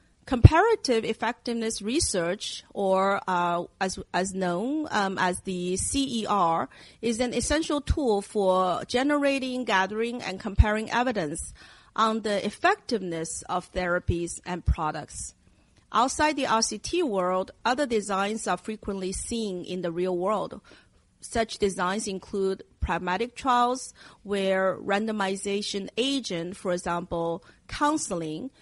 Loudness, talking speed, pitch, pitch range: -27 LUFS, 110 wpm, 200 Hz, 180-235 Hz